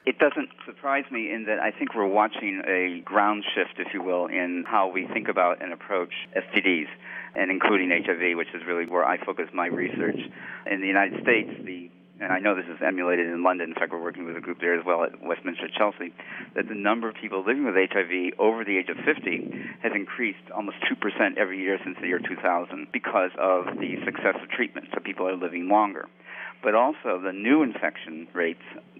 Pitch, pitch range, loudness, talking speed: 90 Hz, 85-100 Hz, -26 LUFS, 220 wpm